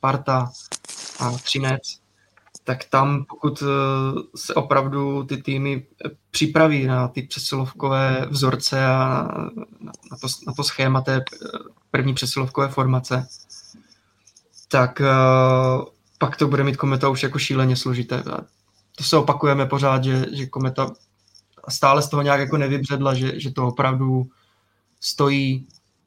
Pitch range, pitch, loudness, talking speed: 130-140 Hz, 135 Hz, -21 LUFS, 120 wpm